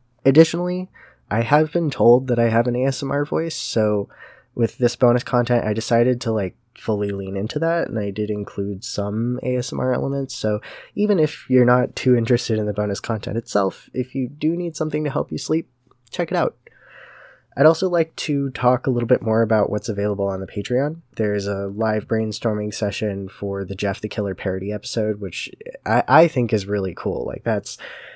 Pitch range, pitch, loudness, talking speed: 105-135 Hz, 120 Hz, -21 LUFS, 195 wpm